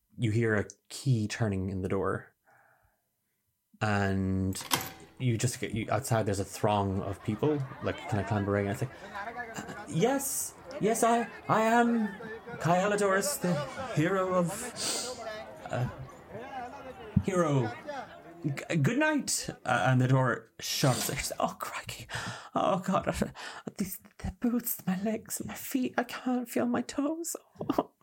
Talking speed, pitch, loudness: 135 wpm, 150 Hz, -31 LUFS